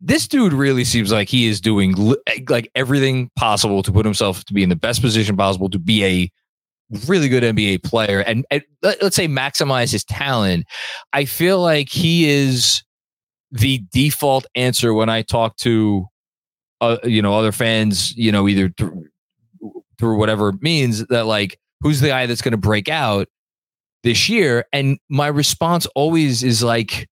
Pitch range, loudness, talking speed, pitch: 105-140 Hz, -17 LUFS, 175 wpm, 120 Hz